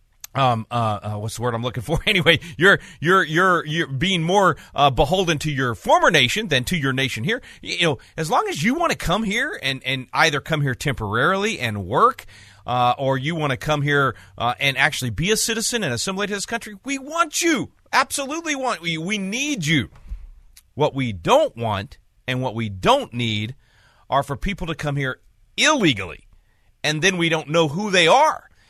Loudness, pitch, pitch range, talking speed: -20 LUFS, 145 Hz, 120-185 Hz, 200 wpm